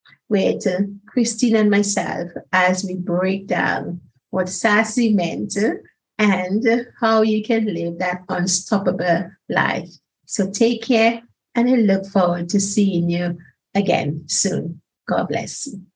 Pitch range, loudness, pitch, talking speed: 180-225 Hz, -19 LUFS, 195 Hz, 130 wpm